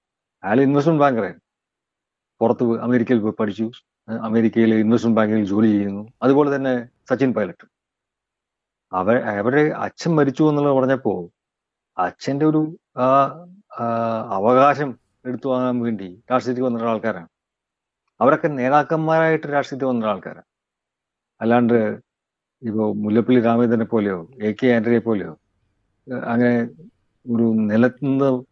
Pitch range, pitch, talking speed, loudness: 110-135 Hz, 120 Hz, 95 wpm, -19 LUFS